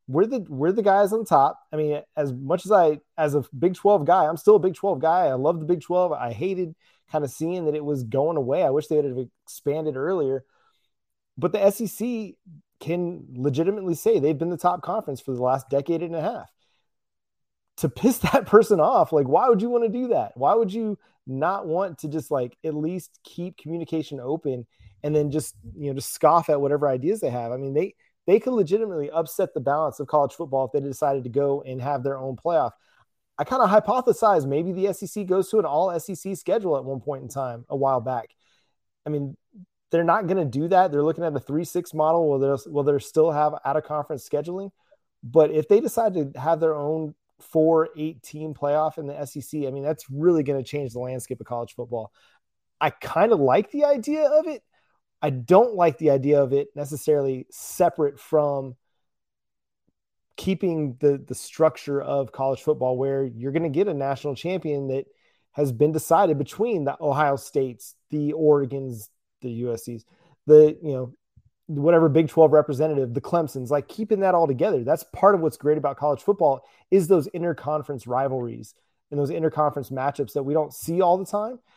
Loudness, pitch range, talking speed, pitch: -23 LUFS, 140-180 Hz, 200 wpm, 155 Hz